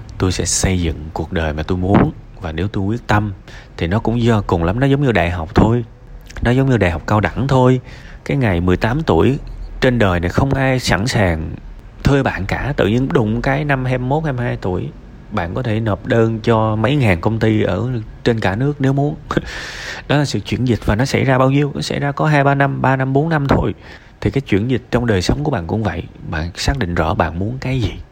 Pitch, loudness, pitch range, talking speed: 115 Hz, -17 LUFS, 95-130 Hz, 245 wpm